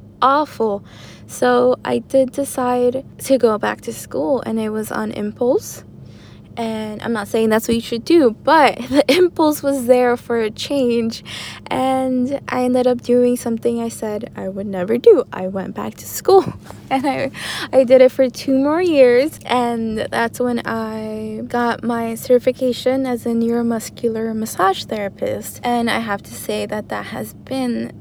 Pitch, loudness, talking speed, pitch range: 245 Hz, -18 LUFS, 170 wpm, 225-260 Hz